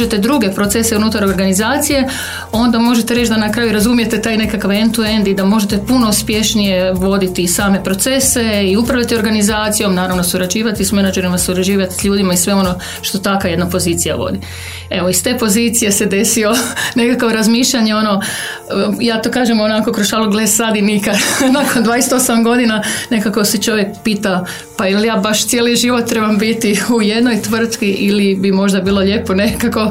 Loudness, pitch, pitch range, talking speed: -13 LUFS, 215 Hz, 195-230 Hz, 170 wpm